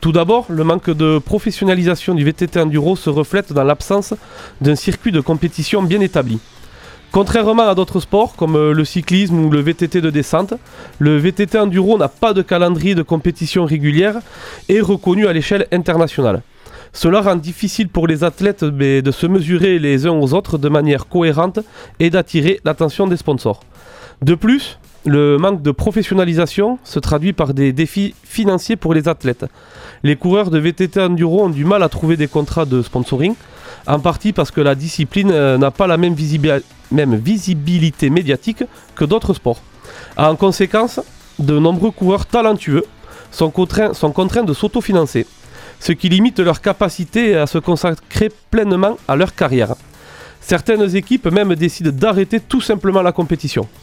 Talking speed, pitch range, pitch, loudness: 160 wpm, 155-200 Hz, 175 Hz, -15 LUFS